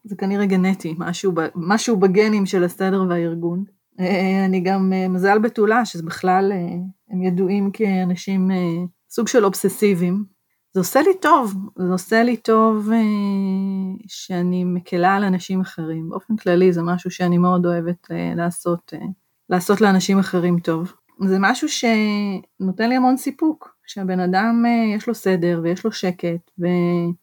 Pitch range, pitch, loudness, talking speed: 180-210 Hz, 190 Hz, -19 LUFS, 135 wpm